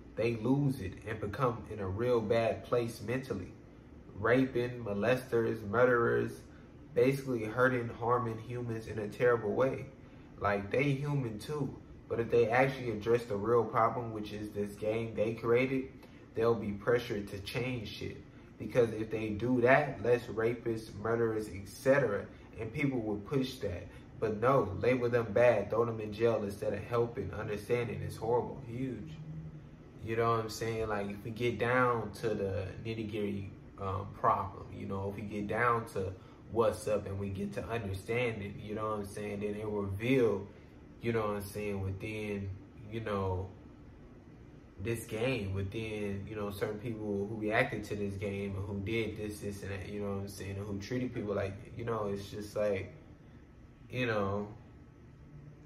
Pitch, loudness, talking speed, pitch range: 110 Hz, -34 LUFS, 170 wpm, 100-120 Hz